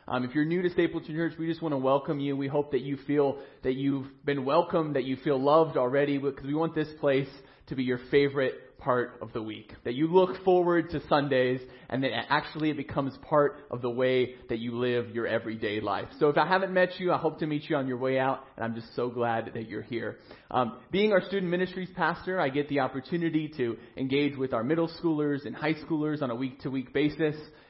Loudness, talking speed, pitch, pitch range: -29 LUFS, 235 wpm, 140 Hz, 125-160 Hz